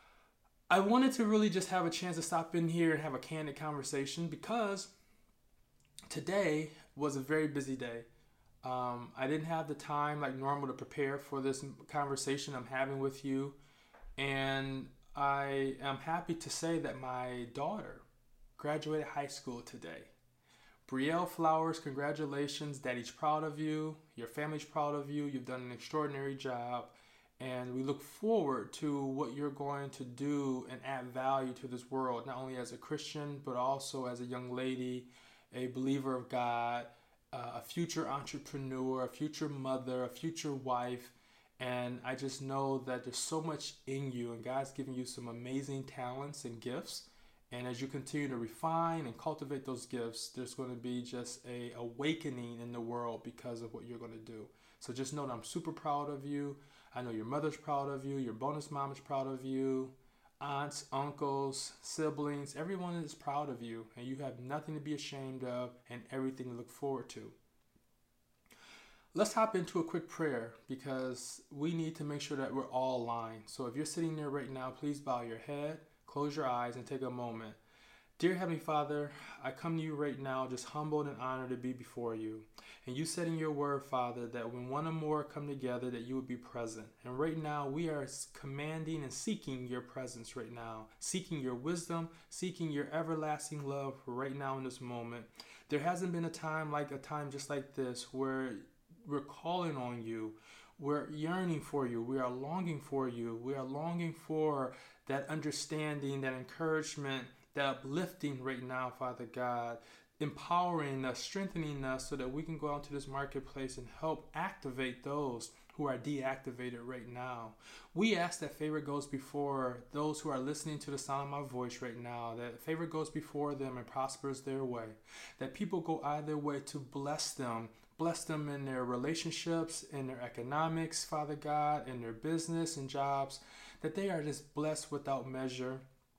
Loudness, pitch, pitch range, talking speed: -39 LUFS, 140 Hz, 125-150 Hz, 180 wpm